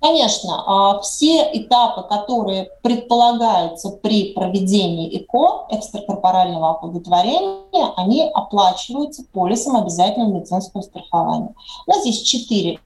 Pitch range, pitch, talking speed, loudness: 185-240 Hz, 210 Hz, 100 wpm, -18 LUFS